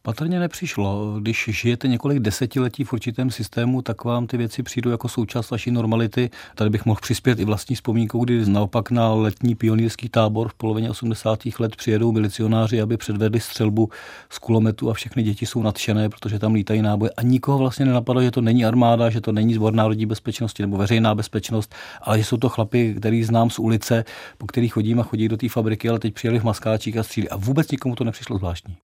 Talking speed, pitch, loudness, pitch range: 205 wpm, 115 Hz, -21 LUFS, 110-120 Hz